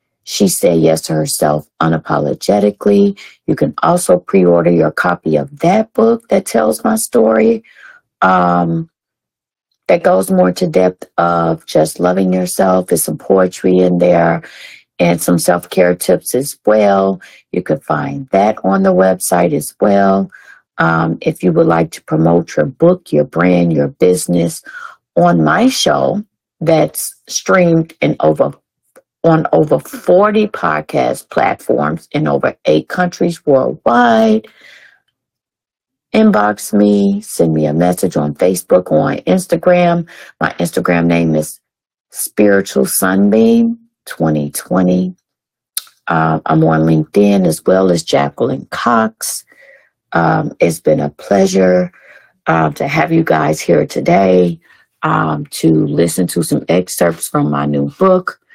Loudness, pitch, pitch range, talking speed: -13 LUFS, 90 Hz, 85-140 Hz, 130 wpm